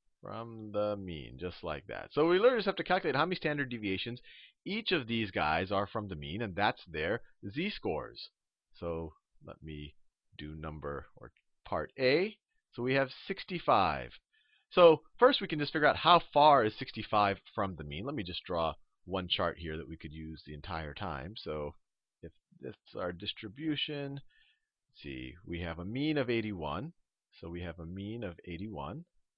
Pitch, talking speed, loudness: 105 Hz, 185 wpm, -33 LUFS